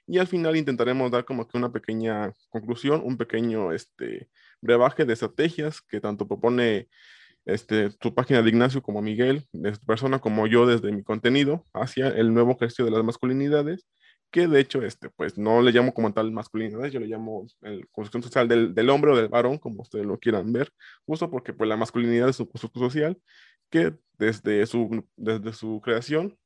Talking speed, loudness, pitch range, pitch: 190 wpm, -24 LUFS, 110-130 Hz, 120 Hz